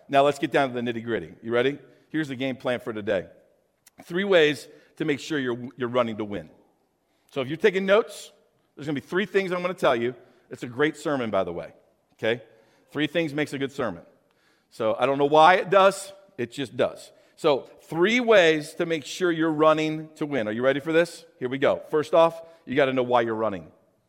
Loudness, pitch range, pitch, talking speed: -24 LUFS, 125-165 Hz, 150 Hz, 225 wpm